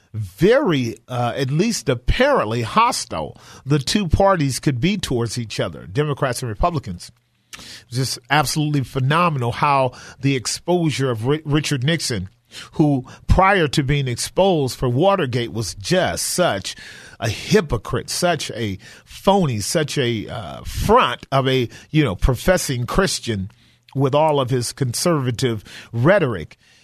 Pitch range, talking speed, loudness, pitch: 120-150 Hz, 130 wpm, -19 LUFS, 135 Hz